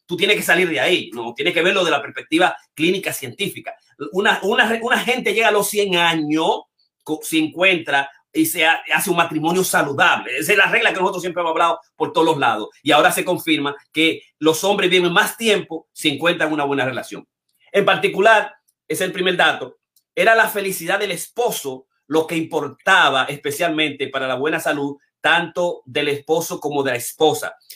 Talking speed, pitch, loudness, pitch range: 190 wpm, 170 Hz, -18 LUFS, 155-200 Hz